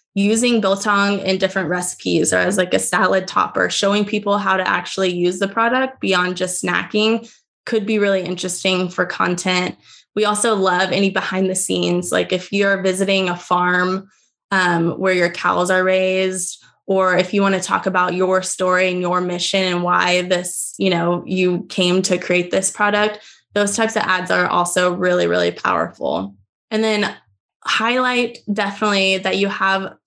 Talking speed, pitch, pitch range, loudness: 170 wpm, 190 Hz, 180-205 Hz, -18 LUFS